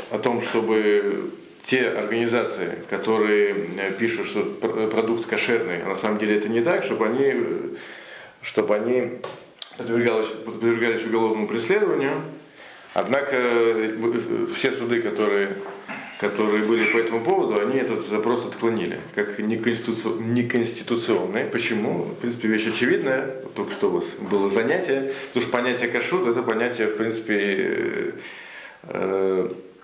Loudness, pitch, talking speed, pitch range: -23 LUFS, 115 Hz, 120 wpm, 105-120 Hz